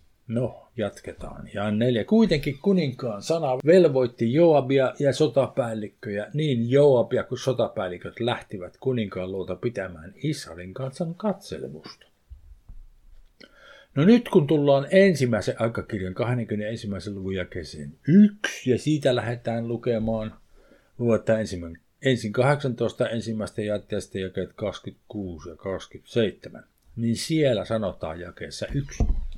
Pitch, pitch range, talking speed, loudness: 115 Hz, 100-140 Hz, 100 wpm, -24 LUFS